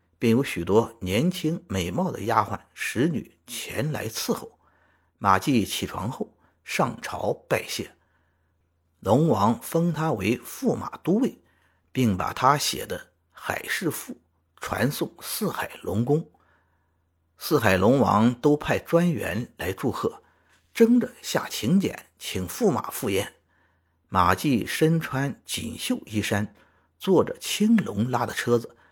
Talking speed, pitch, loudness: 180 characters per minute, 115 Hz, -25 LUFS